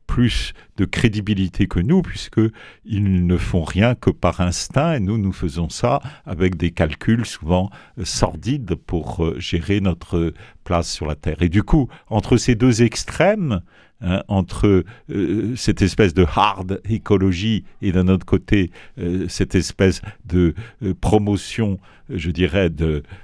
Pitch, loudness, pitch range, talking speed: 95 Hz, -20 LUFS, 90-110 Hz, 155 wpm